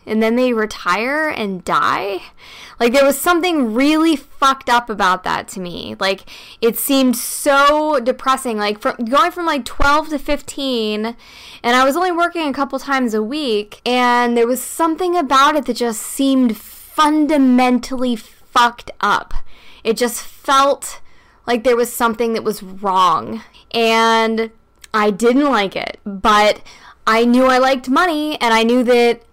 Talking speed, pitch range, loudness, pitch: 160 wpm, 225-280 Hz, -16 LUFS, 245 Hz